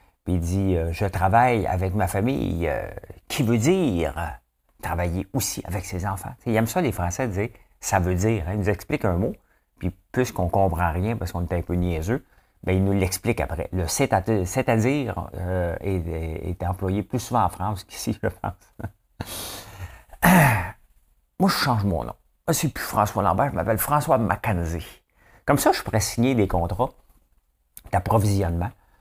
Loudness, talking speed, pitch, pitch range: -24 LUFS, 180 wpm, 95 Hz, 90-115 Hz